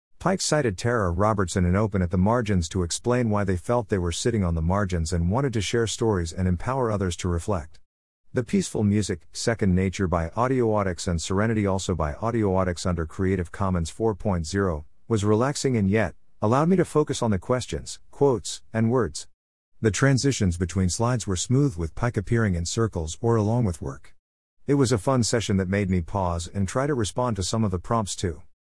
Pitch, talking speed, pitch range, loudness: 100 Hz, 195 wpm, 90-115 Hz, -25 LUFS